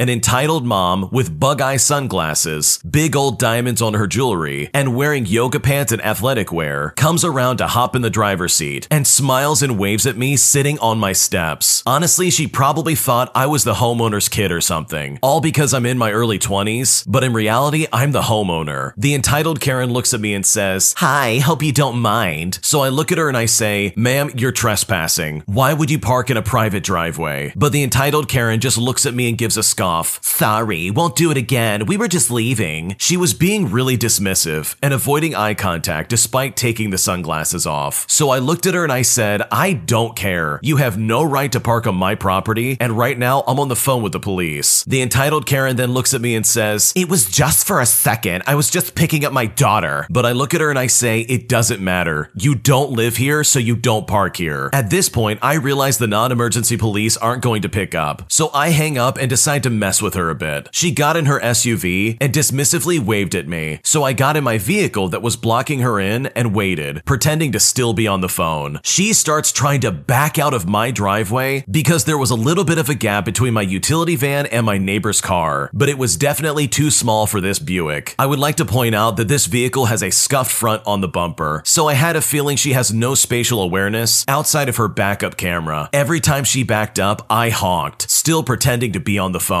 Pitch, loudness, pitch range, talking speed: 120 Hz, -16 LUFS, 105-140 Hz, 225 wpm